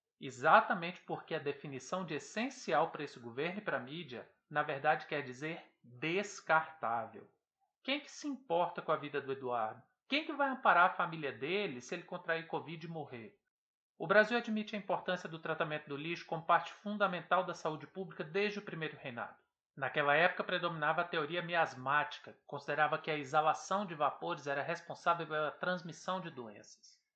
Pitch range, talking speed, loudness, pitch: 150-185 Hz, 170 wpm, -36 LUFS, 165 Hz